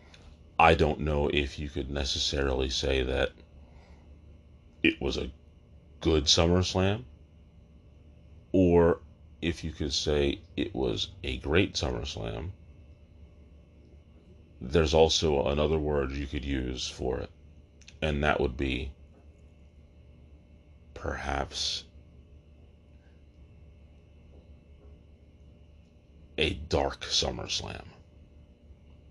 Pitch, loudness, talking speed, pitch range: 80 Hz, -28 LUFS, 90 wpm, 75-80 Hz